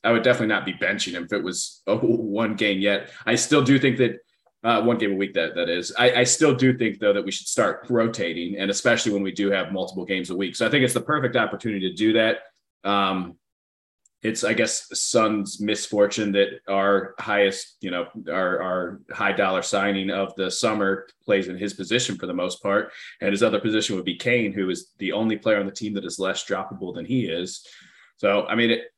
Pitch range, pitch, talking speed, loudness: 95-115 Hz, 105 Hz, 230 wpm, -23 LUFS